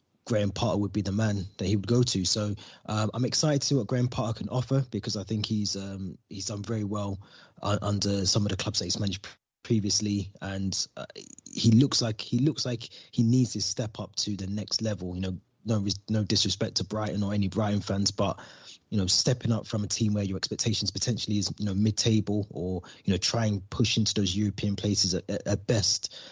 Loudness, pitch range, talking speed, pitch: -28 LUFS, 100-115 Hz, 225 wpm, 105 Hz